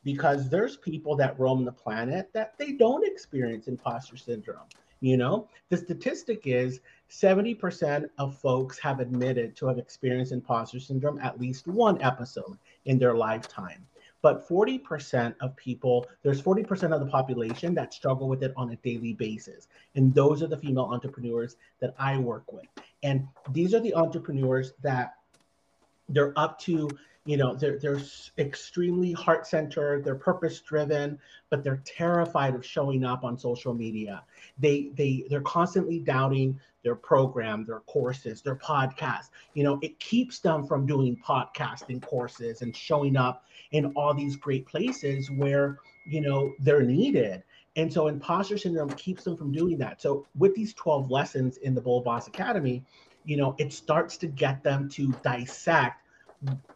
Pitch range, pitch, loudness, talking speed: 125-160 Hz, 140 Hz, -28 LUFS, 160 wpm